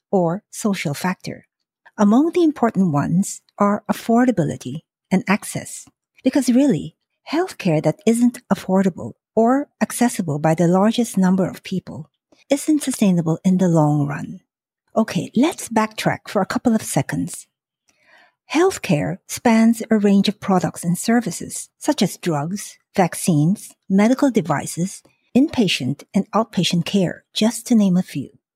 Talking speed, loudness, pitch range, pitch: 130 wpm, -19 LUFS, 175-235 Hz, 205 Hz